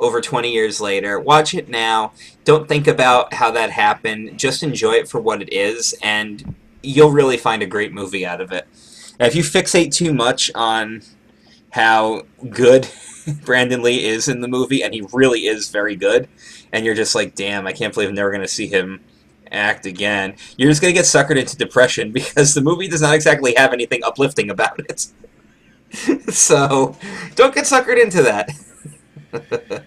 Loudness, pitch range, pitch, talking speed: -16 LUFS, 110-165 Hz, 130 Hz, 185 wpm